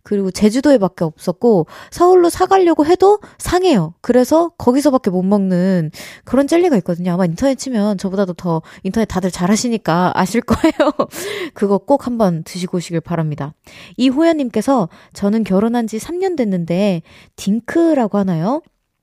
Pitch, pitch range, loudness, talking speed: 215 Hz, 185-280 Hz, -16 LUFS, 345 characters per minute